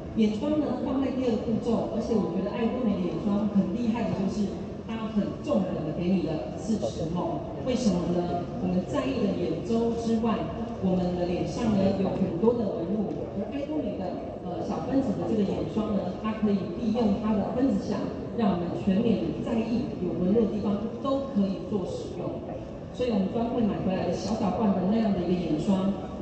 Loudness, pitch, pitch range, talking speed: -28 LUFS, 210 Hz, 190-230 Hz, 290 characters per minute